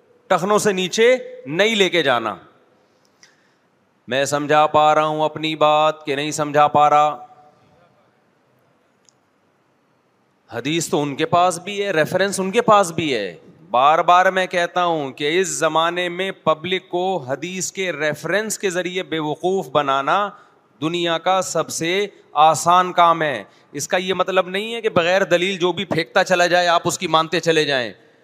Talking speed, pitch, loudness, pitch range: 165 wpm, 175 Hz, -18 LUFS, 155-190 Hz